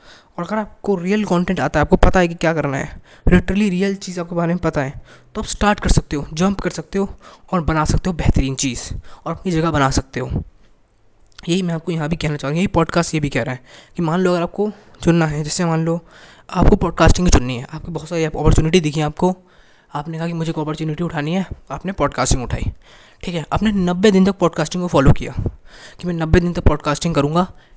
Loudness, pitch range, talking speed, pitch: -19 LUFS, 150-180 Hz, 230 wpm, 165 Hz